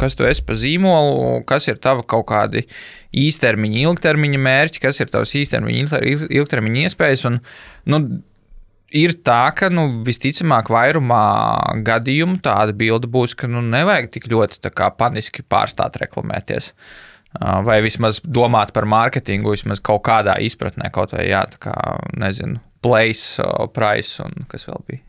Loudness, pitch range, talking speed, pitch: -17 LUFS, 110-145 Hz, 115 wpm, 120 Hz